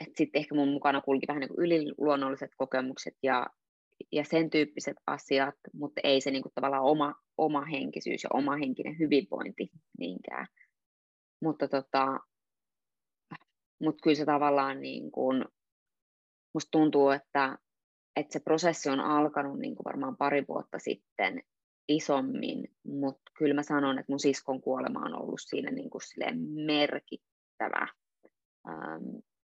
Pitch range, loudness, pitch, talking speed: 135-150 Hz, -31 LUFS, 145 Hz, 135 wpm